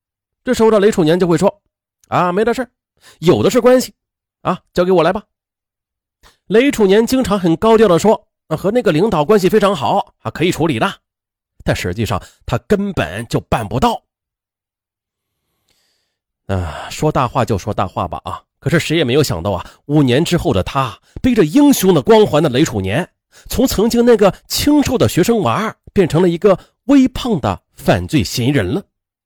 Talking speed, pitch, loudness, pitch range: 255 characters per minute, 180 Hz, -15 LUFS, 130-220 Hz